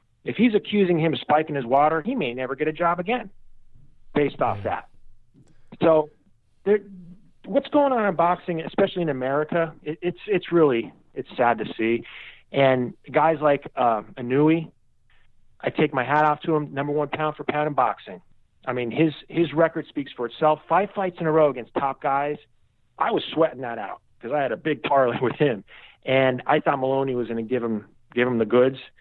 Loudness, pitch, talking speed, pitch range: -23 LUFS, 150 Hz, 200 wpm, 130-165 Hz